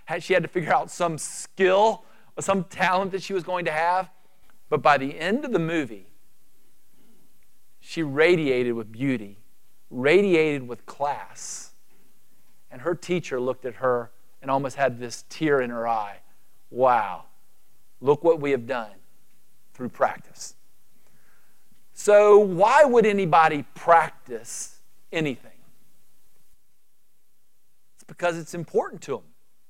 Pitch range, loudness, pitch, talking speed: 130-185 Hz, -23 LUFS, 160 Hz, 130 wpm